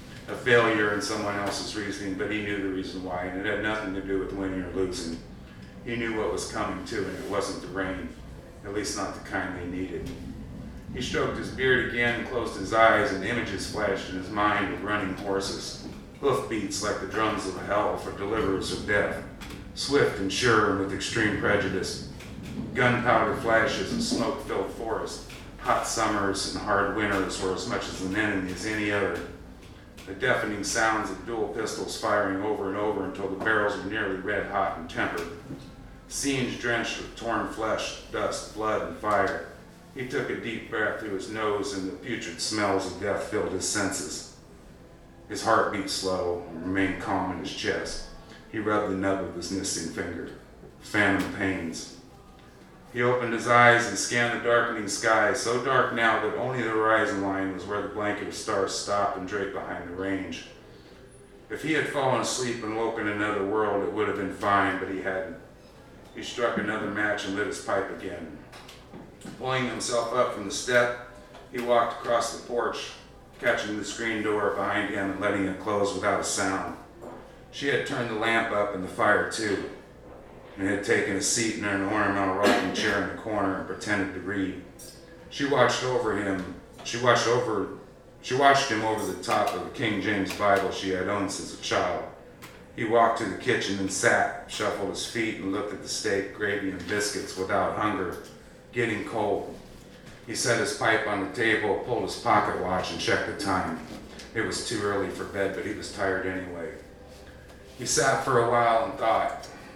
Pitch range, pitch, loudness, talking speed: 95-115 Hz, 100 Hz, -27 LUFS, 190 wpm